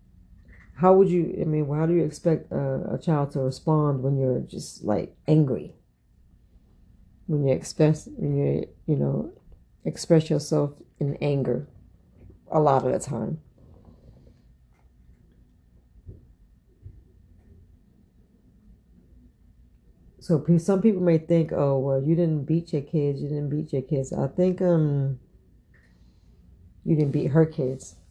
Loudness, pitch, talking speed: -24 LUFS, 135 Hz, 130 wpm